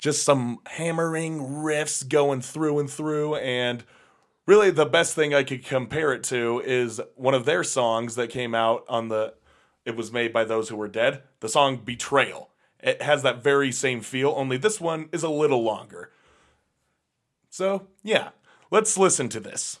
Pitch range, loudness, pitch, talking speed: 120-155 Hz, -24 LUFS, 140 Hz, 175 wpm